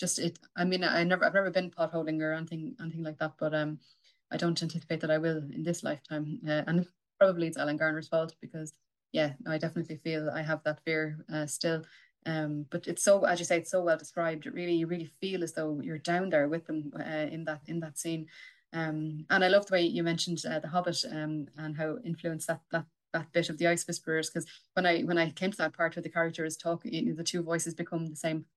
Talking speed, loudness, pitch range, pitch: 250 wpm, -32 LUFS, 155-170 Hz, 165 Hz